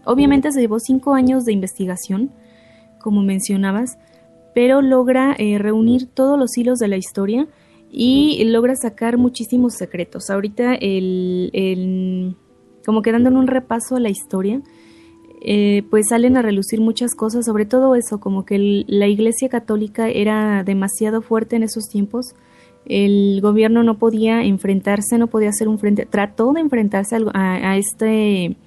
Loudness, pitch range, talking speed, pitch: -17 LUFS, 200-240 Hz, 155 wpm, 220 Hz